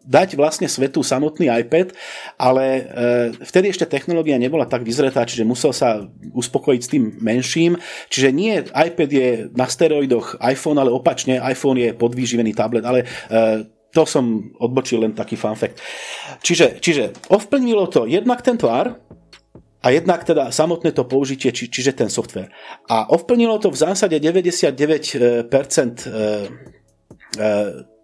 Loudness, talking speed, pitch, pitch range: -18 LUFS, 145 wpm, 135 Hz, 120-165 Hz